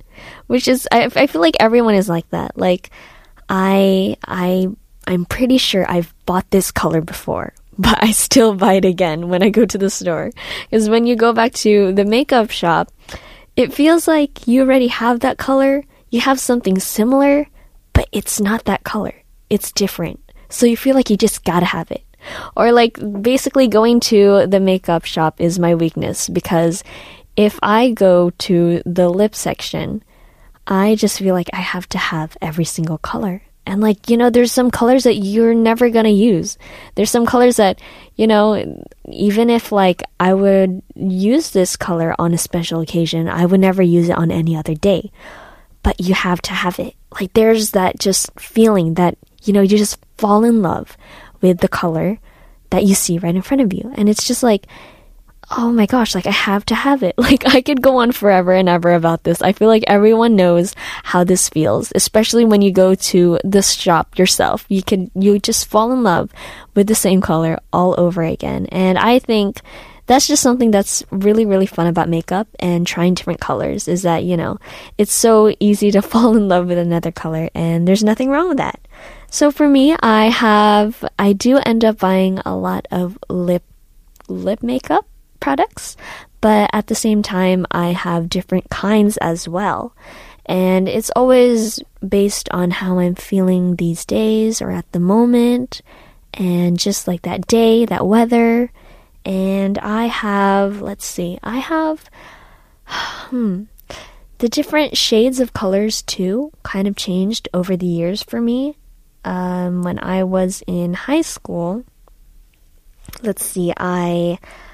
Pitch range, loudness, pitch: 180-230 Hz, -15 LUFS, 200 Hz